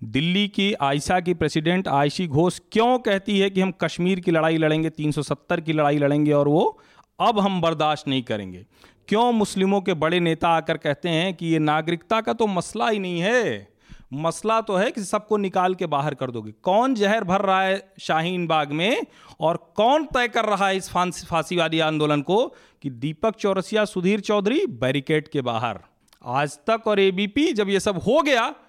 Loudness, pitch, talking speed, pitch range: -22 LUFS, 175 Hz, 190 wpm, 150-200 Hz